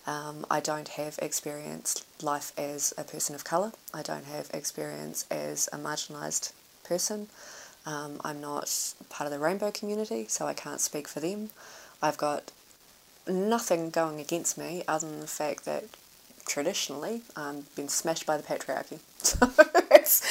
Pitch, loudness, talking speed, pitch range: 155 Hz, -30 LUFS, 150 wpm, 145-190 Hz